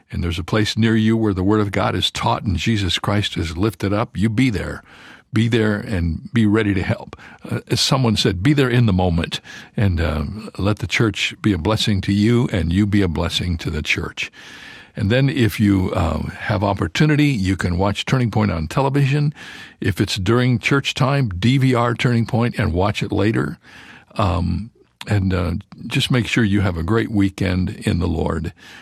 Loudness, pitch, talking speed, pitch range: -19 LUFS, 105 Hz, 200 wpm, 95-115 Hz